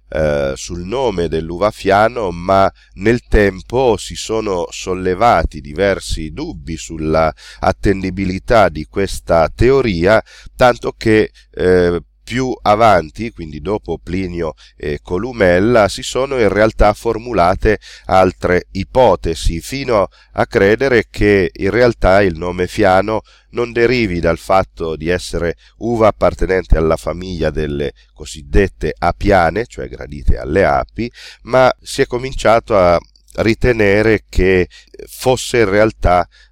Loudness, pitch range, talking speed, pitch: -15 LUFS, 80-110 Hz, 115 wpm, 95 Hz